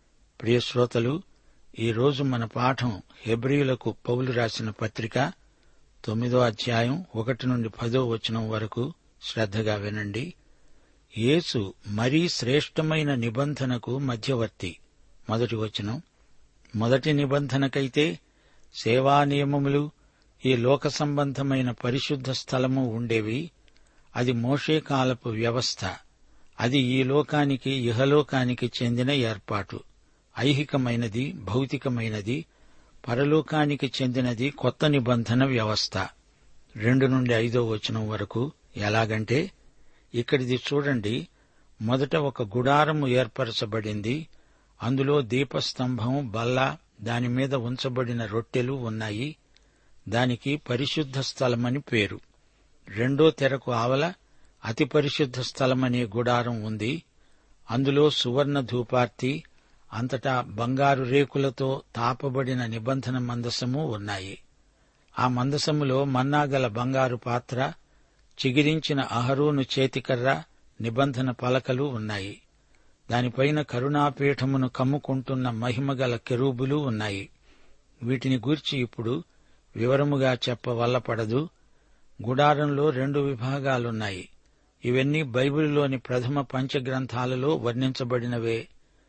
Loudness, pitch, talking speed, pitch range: -26 LUFS, 130 Hz, 85 wpm, 120-140 Hz